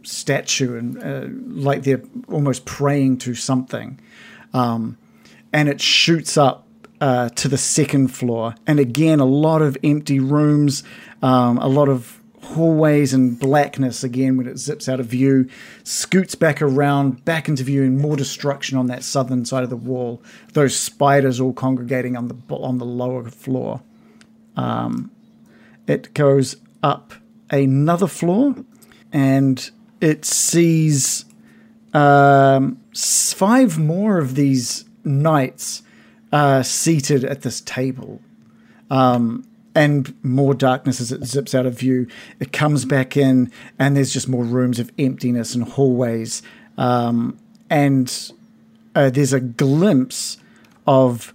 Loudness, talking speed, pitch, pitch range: -18 LUFS, 135 wpm, 140 Hz, 130-160 Hz